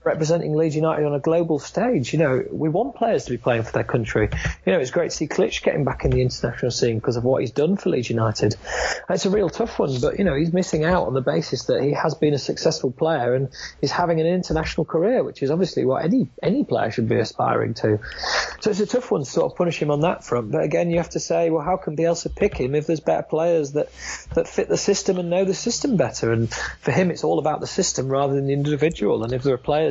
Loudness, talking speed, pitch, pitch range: -22 LUFS, 270 wpm, 155 Hz, 135-175 Hz